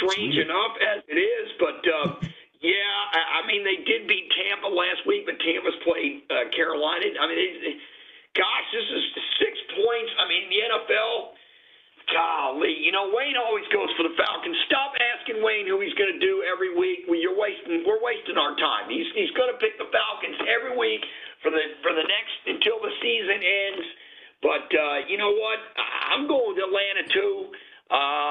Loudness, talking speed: -24 LUFS, 190 wpm